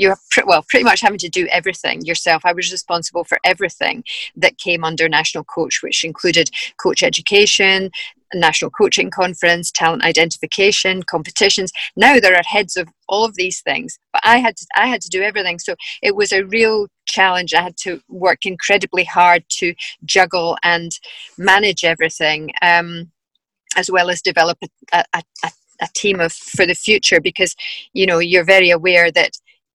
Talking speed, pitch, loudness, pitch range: 175 wpm, 180 Hz, -14 LUFS, 170-195 Hz